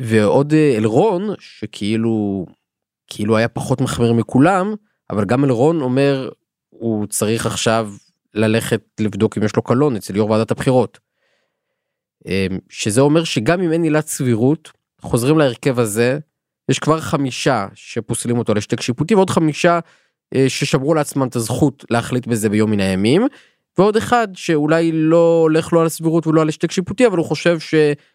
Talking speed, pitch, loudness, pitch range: 150 wpm, 135 Hz, -17 LUFS, 115-160 Hz